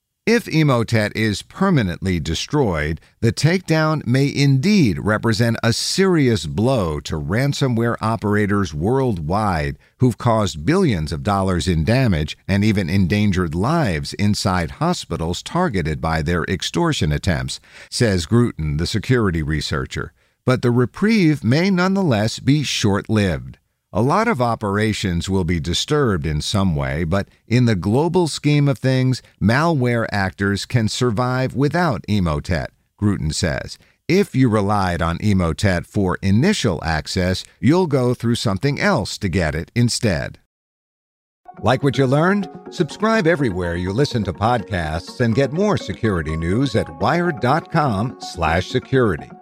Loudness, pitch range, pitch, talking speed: -19 LUFS, 90-135 Hz, 110 Hz, 130 wpm